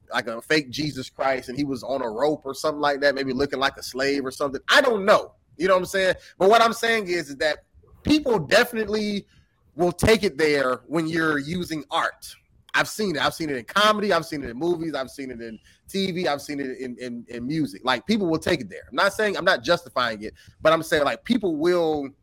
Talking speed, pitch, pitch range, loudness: 245 wpm, 155 Hz, 135-185 Hz, -23 LUFS